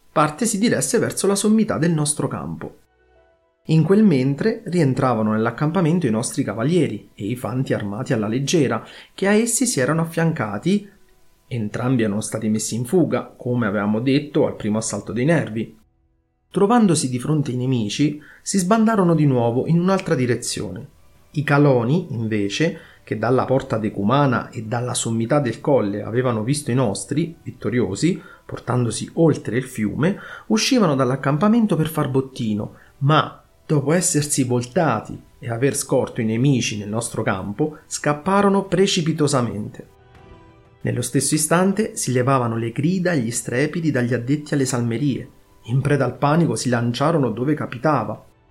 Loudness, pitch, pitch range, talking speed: -20 LUFS, 135 Hz, 115-160 Hz, 145 wpm